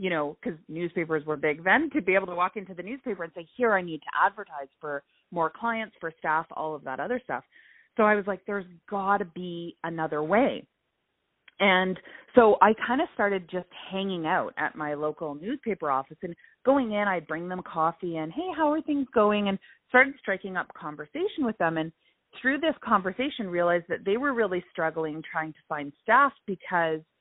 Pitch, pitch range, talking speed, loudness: 185 Hz, 160-220 Hz, 200 wpm, -27 LUFS